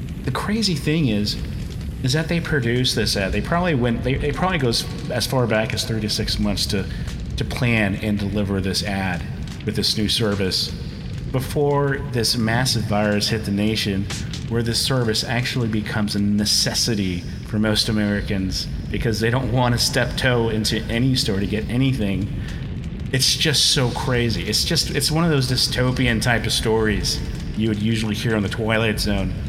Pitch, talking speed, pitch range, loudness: 115 Hz, 180 wpm, 105-130 Hz, -21 LUFS